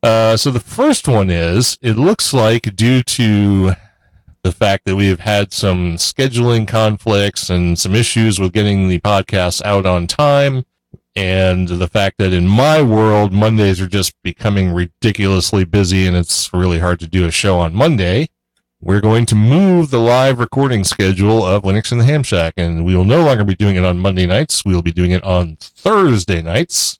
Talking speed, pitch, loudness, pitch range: 190 wpm, 100 Hz, -13 LUFS, 90-115 Hz